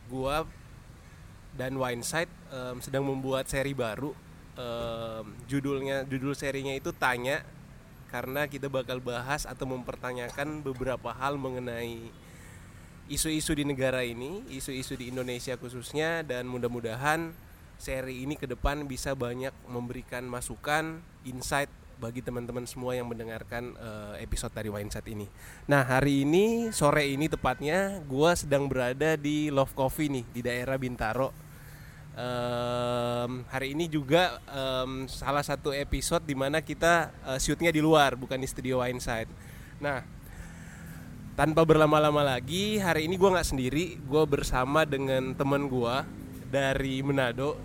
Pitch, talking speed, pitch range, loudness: 130 Hz, 130 wpm, 125-145 Hz, -30 LUFS